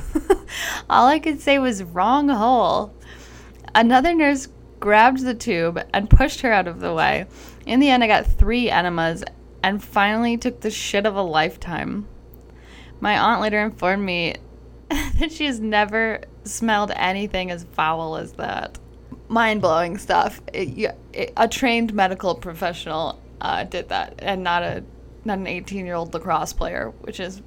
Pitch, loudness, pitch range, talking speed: 210 Hz, -21 LUFS, 175-240 Hz, 155 wpm